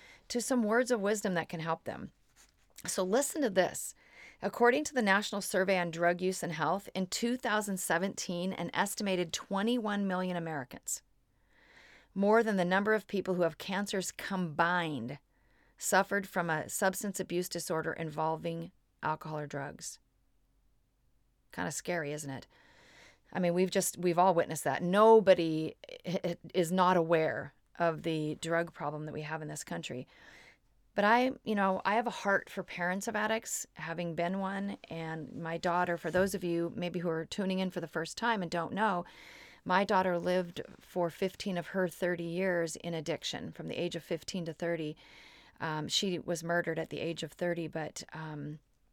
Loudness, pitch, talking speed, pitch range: -33 LUFS, 175 Hz, 170 wpm, 165-195 Hz